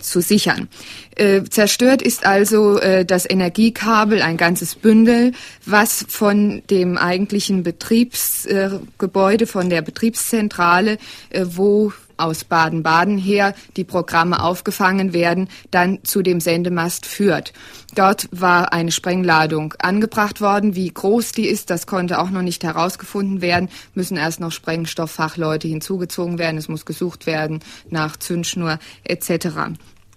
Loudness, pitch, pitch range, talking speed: -17 LUFS, 185 Hz, 170-205 Hz, 130 wpm